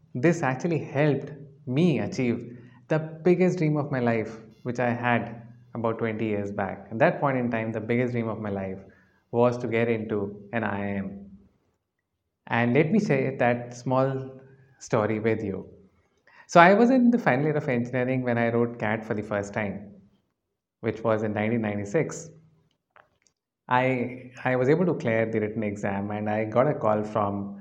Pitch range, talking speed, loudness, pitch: 110-135 Hz, 175 wpm, -25 LUFS, 120 Hz